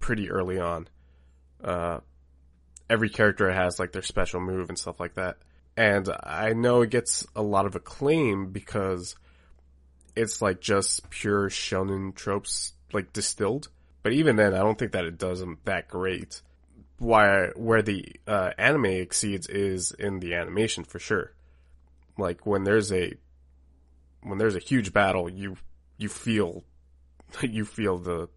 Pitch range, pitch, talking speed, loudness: 70-100 Hz, 90 Hz, 150 wpm, -27 LUFS